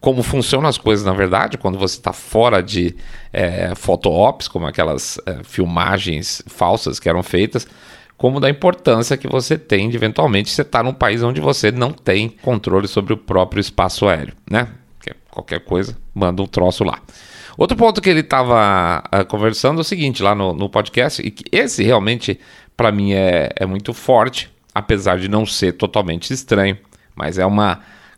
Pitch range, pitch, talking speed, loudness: 95-120 Hz, 105 Hz, 180 wpm, -17 LUFS